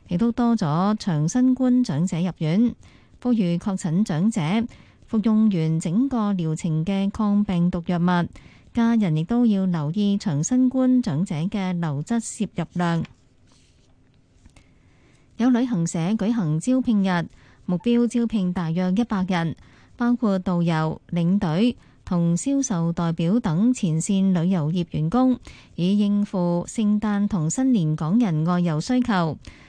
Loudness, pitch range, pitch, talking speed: -22 LUFS, 170-230 Hz, 190 Hz, 200 characters per minute